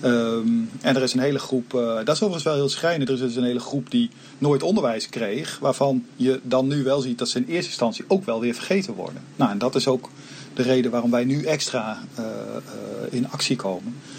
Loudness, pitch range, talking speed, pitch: -23 LUFS, 125-140 Hz, 235 wpm, 130 Hz